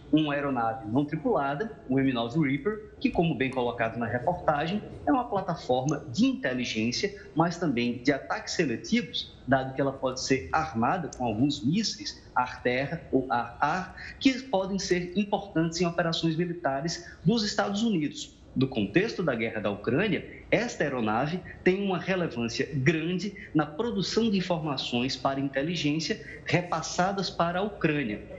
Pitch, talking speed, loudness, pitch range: 160 Hz, 140 wpm, -28 LUFS, 130-185 Hz